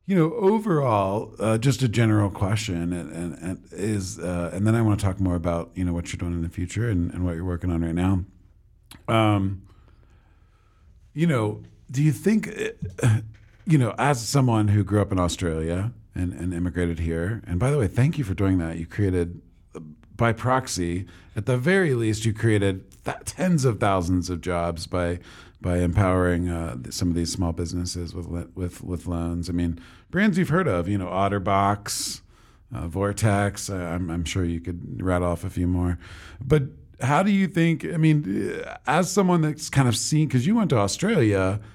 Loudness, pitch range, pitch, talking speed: -24 LUFS, 90-115 Hz, 95 Hz, 195 wpm